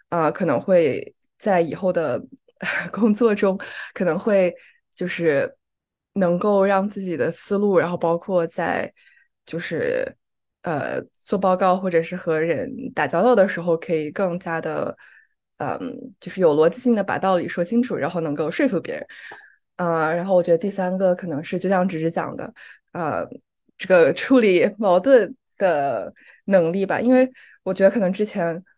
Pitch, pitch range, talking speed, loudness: 190 Hz, 170-230 Hz, 235 characters per minute, -21 LUFS